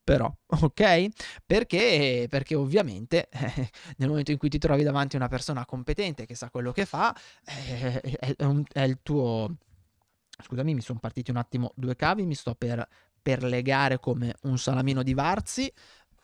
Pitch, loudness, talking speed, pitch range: 135 Hz, -27 LUFS, 165 wpm, 125-150 Hz